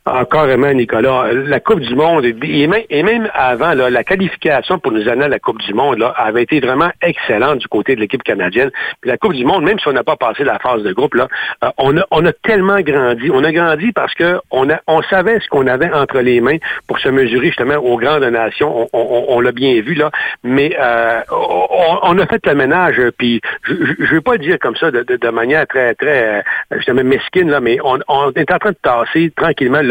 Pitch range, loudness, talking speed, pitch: 125-190 Hz, -13 LUFS, 245 wpm, 150 Hz